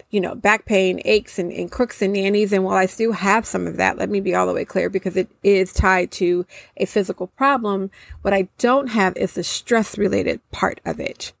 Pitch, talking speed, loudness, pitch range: 195 Hz, 230 wpm, -20 LUFS, 185-210 Hz